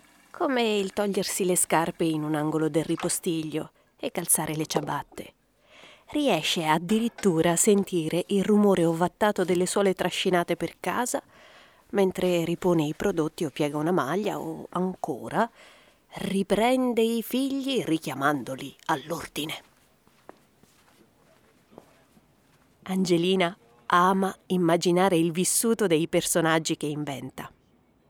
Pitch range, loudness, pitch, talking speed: 160-200 Hz, -26 LUFS, 180 Hz, 105 wpm